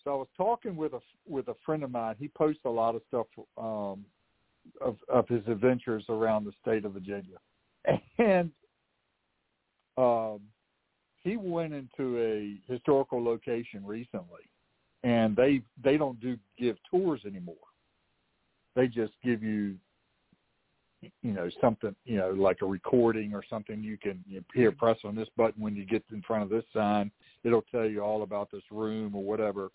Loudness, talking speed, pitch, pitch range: -31 LUFS, 170 wpm, 110 Hz, 105-125 Hz